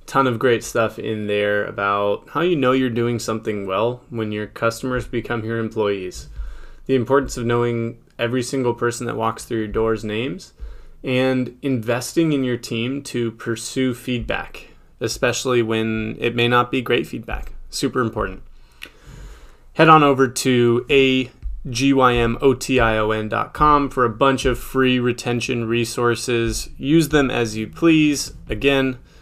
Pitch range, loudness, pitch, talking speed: 115-130 Hz, -20 LUFS, 120 Hz, 160 wpm